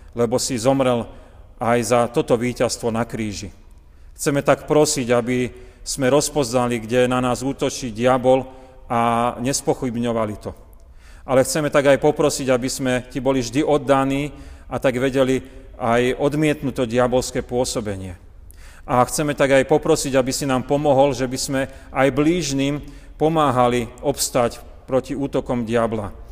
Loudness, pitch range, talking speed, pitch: -20 LUFS, 120-140 Hz, 140 wpm, 130 Hz